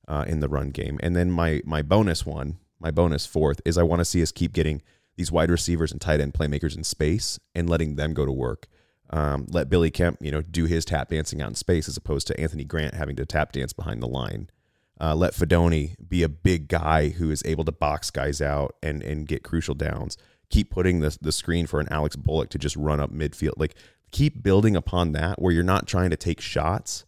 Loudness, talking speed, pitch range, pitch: -25 LUFS, 235 wpm, 75-85 Hz, 80 Hz